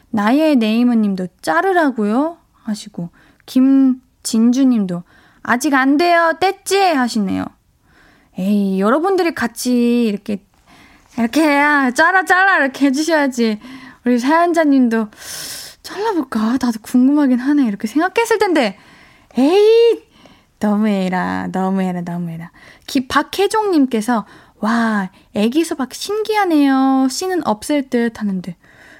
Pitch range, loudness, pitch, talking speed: 215-320 Hz, -16 LUFS, 260 Hz, 265 characters per minute